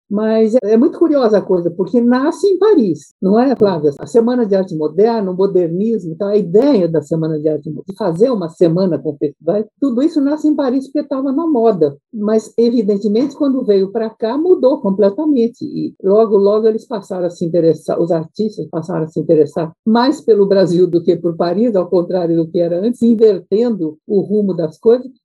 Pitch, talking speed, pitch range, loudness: 210 Hz, 195 wpm, 175-235 Hz, -15 LUFS